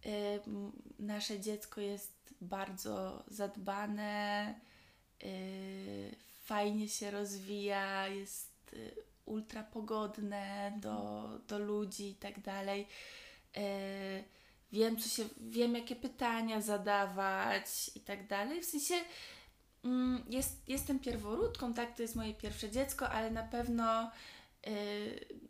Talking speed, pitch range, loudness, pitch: 95 wpm, 200-235 Hz, -40 LUFS, 210 Hz